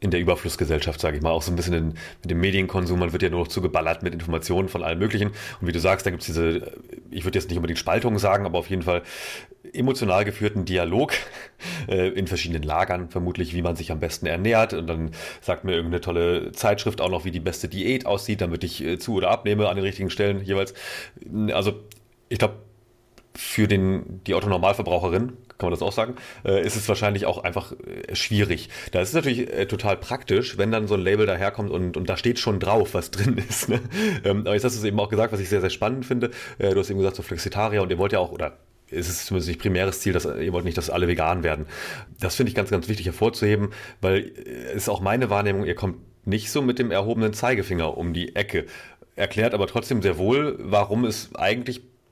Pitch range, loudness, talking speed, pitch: 90-110 Hz, -24 LUFS, 225 wpm, 100 Hz